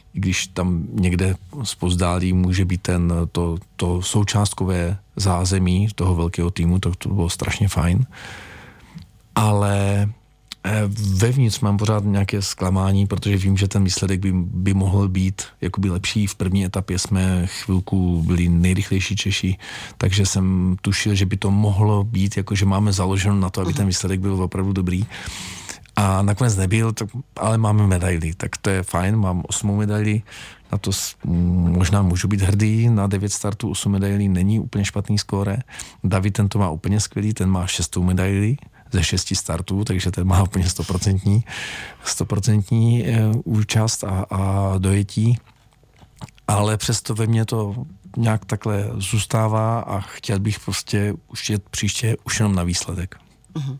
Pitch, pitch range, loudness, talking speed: 100 Hz, 95-105 Hz, -21 LUFS, 150 wpm